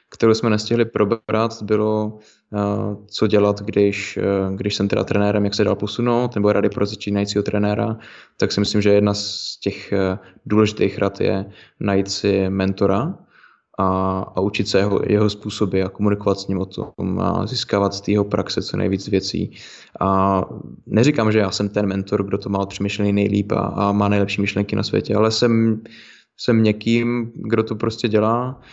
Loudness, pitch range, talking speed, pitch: -20 LUFS, 100-110 Hz, 175 wpm, 105 Hz